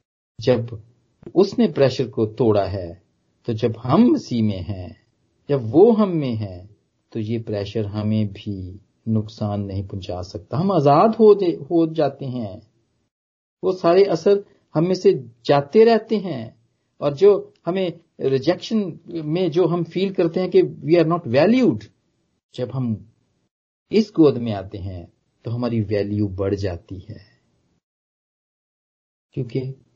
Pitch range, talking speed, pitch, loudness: 105-170 Hz, 135 wpm, 125 Hz, -20 LUFS